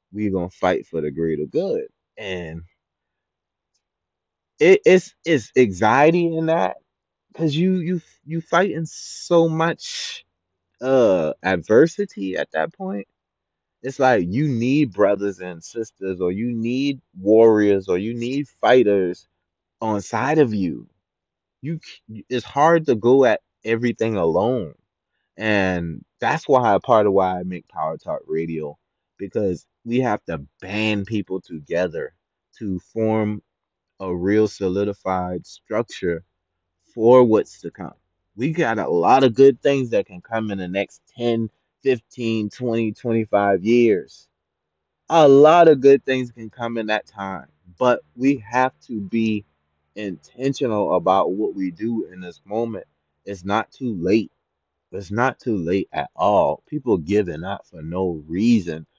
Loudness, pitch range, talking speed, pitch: -20 LUFS, 90-125 Hz, 140 wpm, 105 Hz